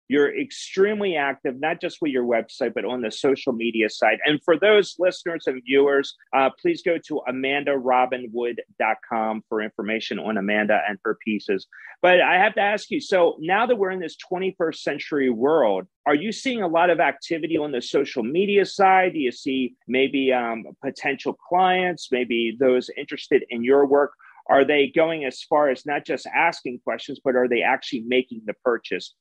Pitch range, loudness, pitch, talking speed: 125-175 Hz, -22 LUFS, 140 Hz, 185 wpm